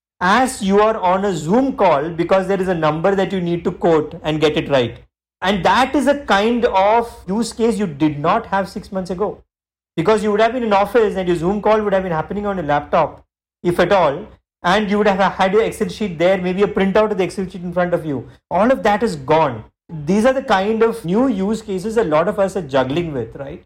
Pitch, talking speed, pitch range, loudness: 195 Hz, 250 wpm, 170-215 Hz, -17 LUFS